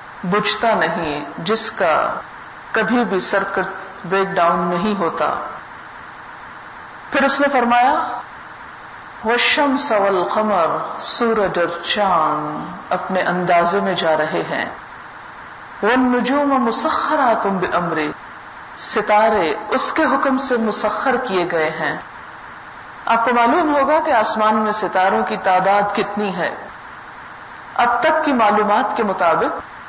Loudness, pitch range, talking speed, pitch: -17 LUFS, 185-245 Hz, 120 wpm, 215 Hz